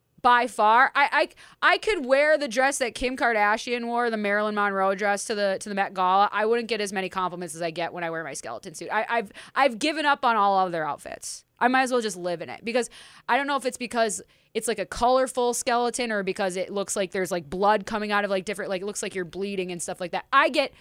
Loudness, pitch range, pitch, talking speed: -24 LUFS, 190-245 Hz, 215 Hz, 270 wpm